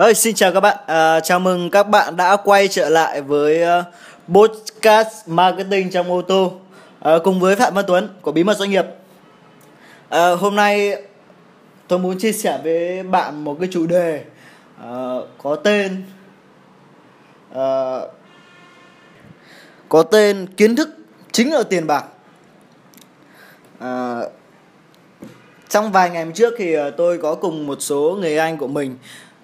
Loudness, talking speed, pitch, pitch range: -17 LUFS, 145 wpm, 180 Hz, 160-200 Hz